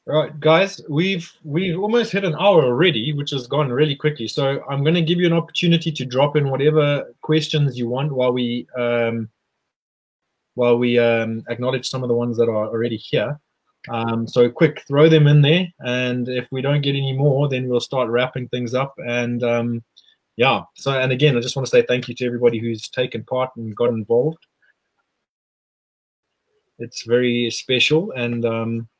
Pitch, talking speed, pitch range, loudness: 130 Hz, 185 wpm, 120-150 Hz, -19 LUFS